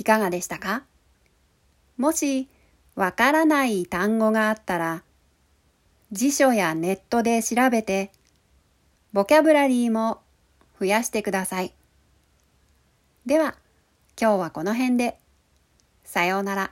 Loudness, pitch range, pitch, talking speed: -23 LUFS, 160-235 Hz, 200 Hz, 225 characters per minute